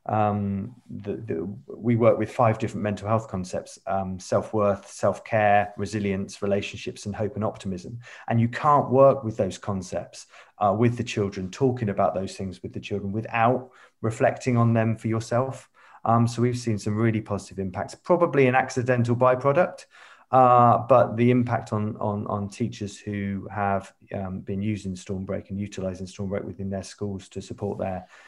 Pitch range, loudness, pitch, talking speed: 100-120 Hz, -25 LUFS, 105 Hz, 170 wpm